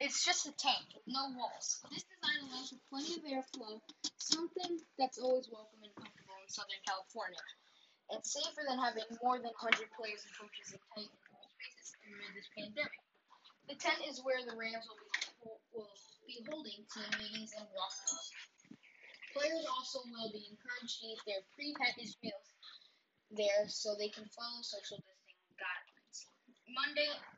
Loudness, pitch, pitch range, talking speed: -40 LUFS, 230 Hz, 210-275 Hz, 160 wpm